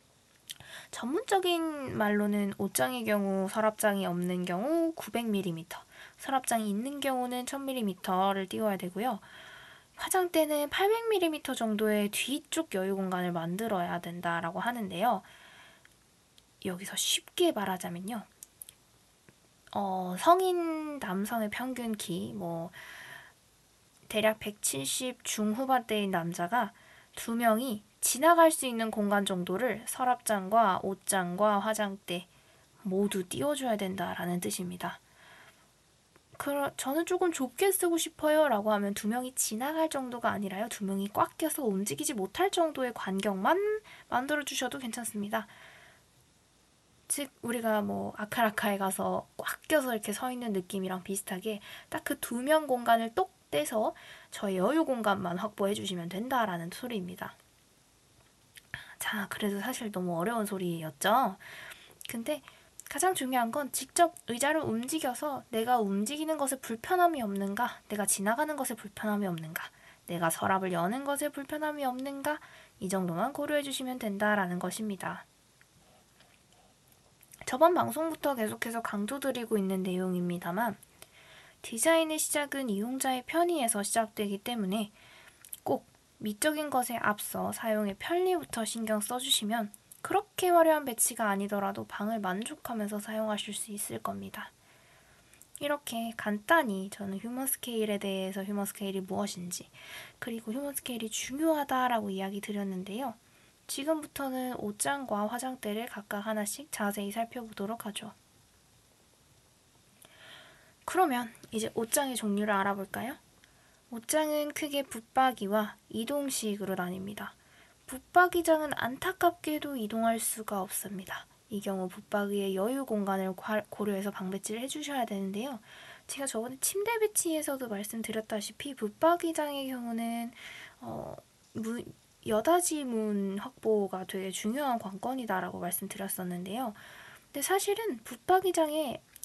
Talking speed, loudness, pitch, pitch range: 290 characters per minute, -32 LUFS, 225 Hz, 200-280 Hz